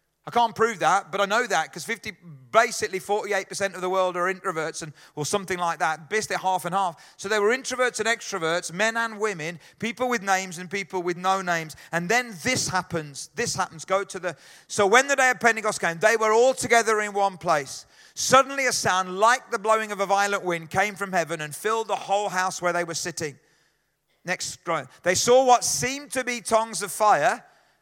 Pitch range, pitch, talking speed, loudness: 175-225 Hz, 195 Hz, 215 wpm, -24 LUFS